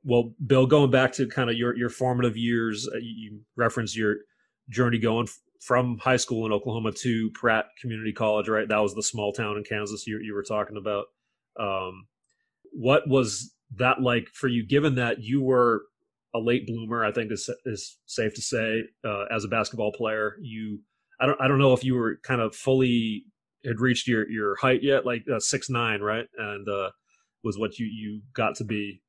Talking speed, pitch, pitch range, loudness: 200 wpm, 115 Hz, 110-130 Hz, -26 LUFS